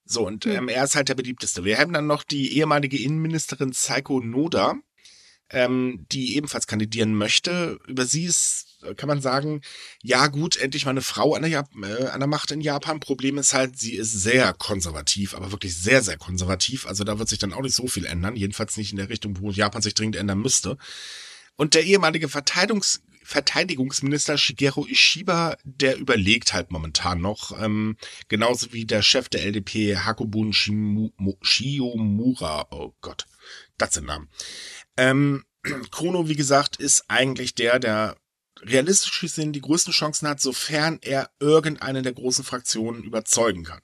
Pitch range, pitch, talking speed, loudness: 105-145 Hz, 130 Hz, 170 wpm, -22 LUFS